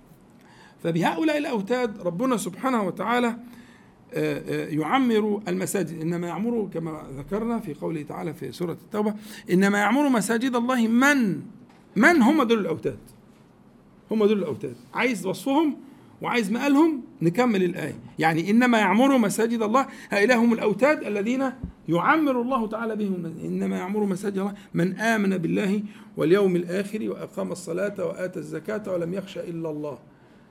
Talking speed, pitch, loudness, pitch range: 130 wpm, 205 Hz, -24 LUFS, 175-240 Hz